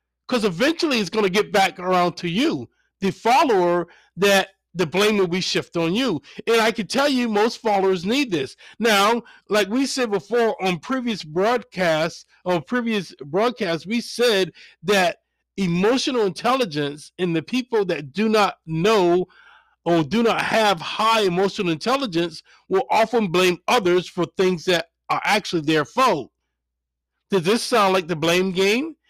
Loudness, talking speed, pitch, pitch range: -21 LUFS, 160 wpm, 200 Hz, 175-230 Hz